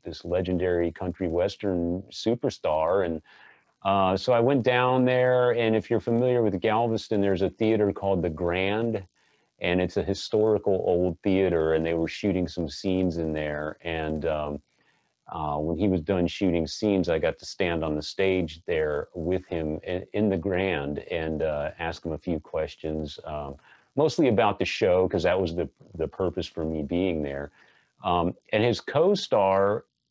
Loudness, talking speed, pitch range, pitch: -26 LUFS, 175 wpm, 80-100 Hz, 90 Hz